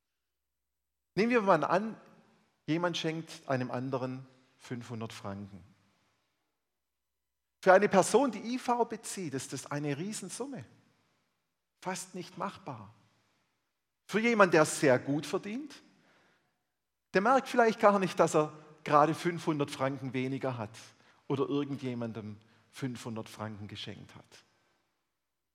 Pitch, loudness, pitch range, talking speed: 145 Hz, -31 LUFS, 115-185 Hz, 110 wpm